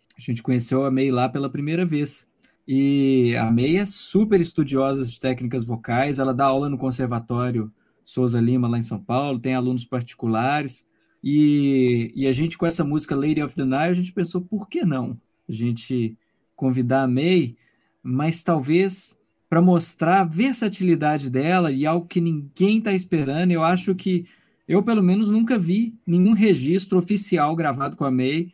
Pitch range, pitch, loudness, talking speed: 130-180 Hz, 145 Hz, -21 LUFS, 170 wpm